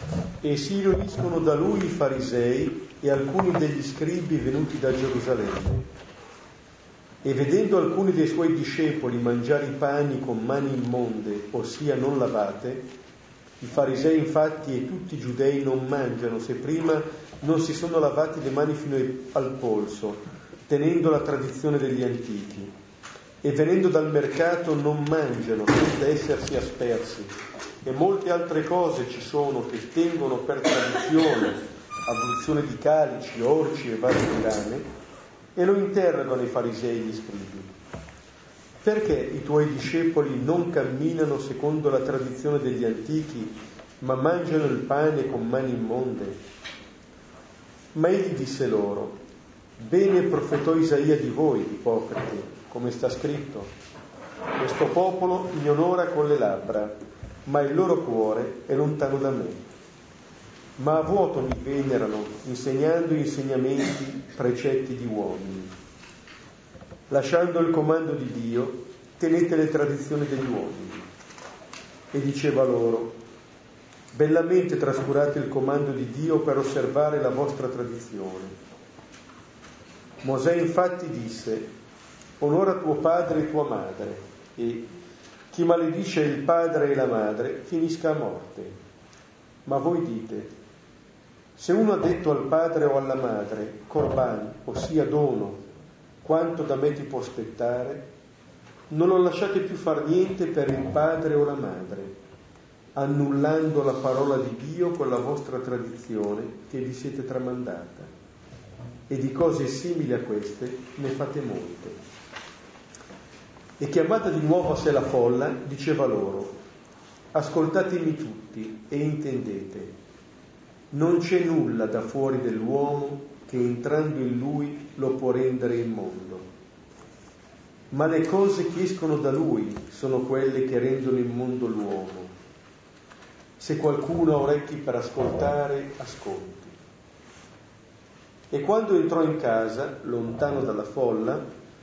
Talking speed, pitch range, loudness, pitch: 125 wpm, 125-155 Hz, -25 LUFS, 140 Hz